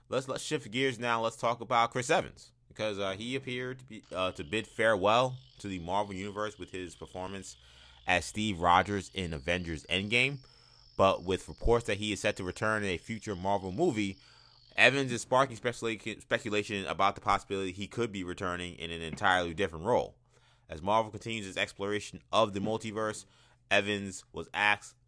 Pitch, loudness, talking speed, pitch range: 105 Hz, -31 LUFS, 180 wpm, 95-115 Hz